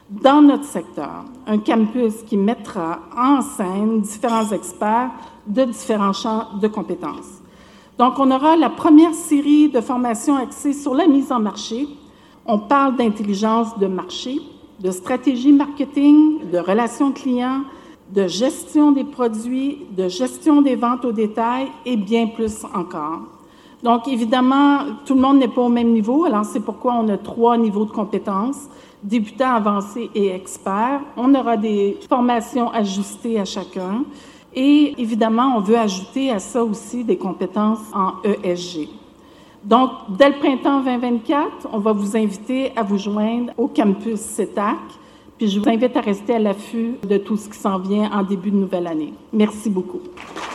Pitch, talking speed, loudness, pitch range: 235 Hz, 160 wpm, -18 LUFS, 210-270 Hz